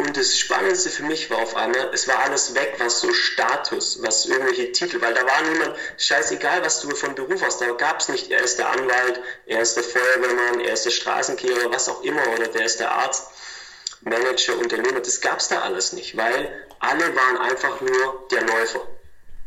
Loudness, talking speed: -20 LUFS, 205 wpm